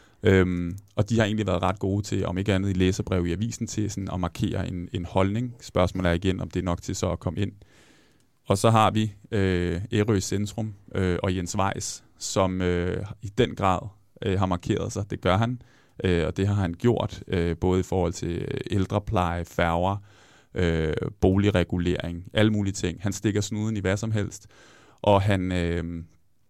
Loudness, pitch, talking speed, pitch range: -26 LUFS, 95 Hz, 190 wpm, 90-105 Hz